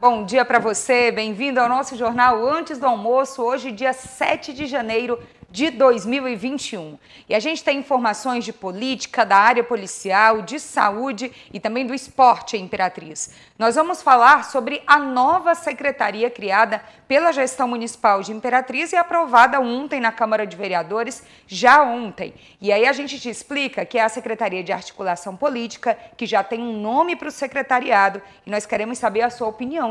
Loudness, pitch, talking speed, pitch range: -19 LUFS, 240 Hz, 170 wpm, 220-270 Hz